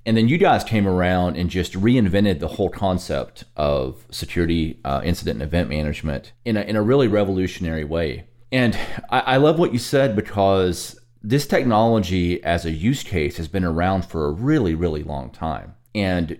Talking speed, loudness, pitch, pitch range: 185 wpm, -21 LUFS, 95 Hz, 85-115 Hz